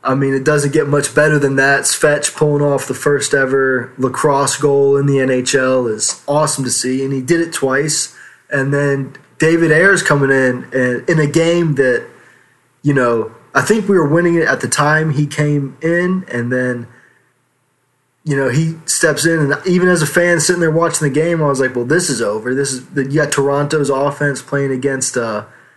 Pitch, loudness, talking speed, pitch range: 140 Hz, -14 LUFS, 205 wpm, 130-155 Hz